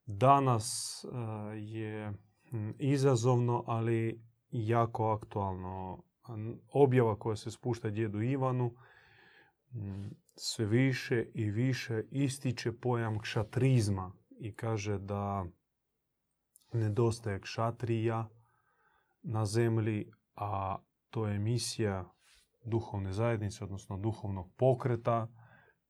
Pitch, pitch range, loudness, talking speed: 115 Hz, 105-120 Hz, -34 LUFS, 80 wpm